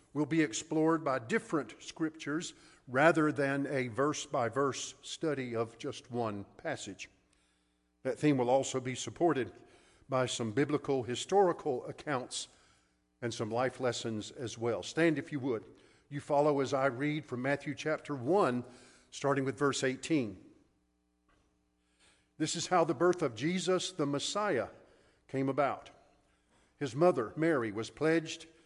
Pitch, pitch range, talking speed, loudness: 140 Hz, 120-155 Hz, 140 wpm, -33 LUFS